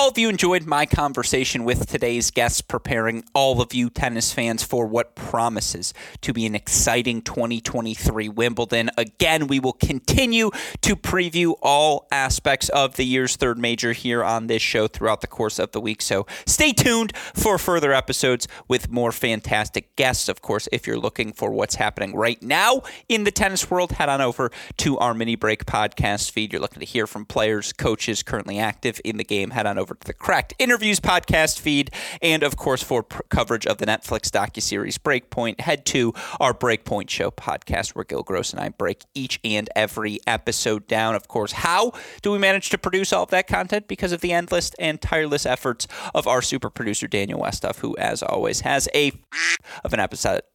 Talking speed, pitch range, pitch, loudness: 195 wpm, 115-160 Hz, 125 Hz, -22 LUFS